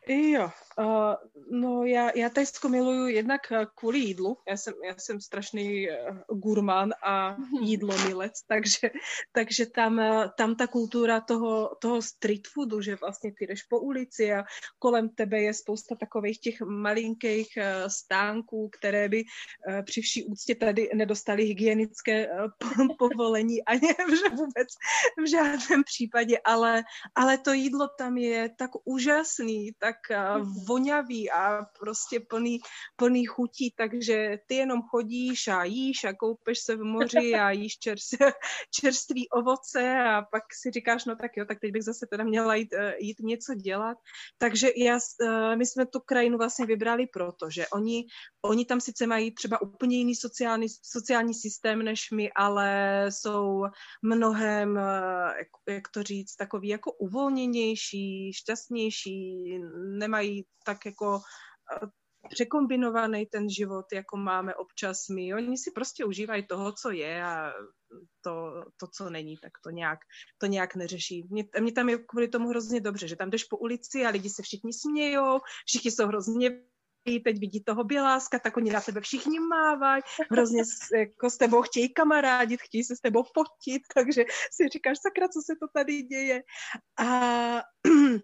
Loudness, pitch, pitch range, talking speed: -28 LUFS, 225 Hz, 210-245 Hz, 150 wpm